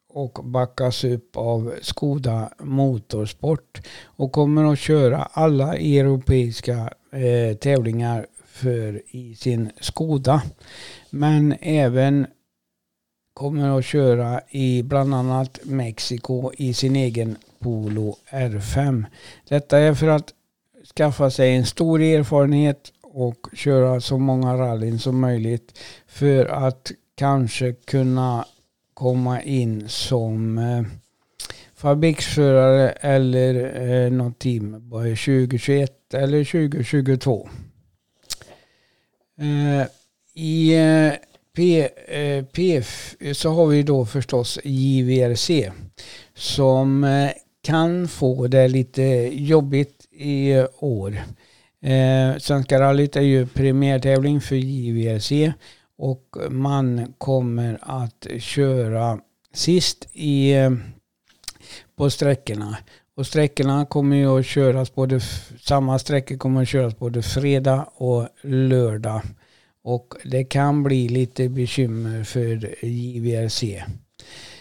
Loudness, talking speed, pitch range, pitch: -20 LUFS, 95 wpm, 120-140 Hz, 130 Hz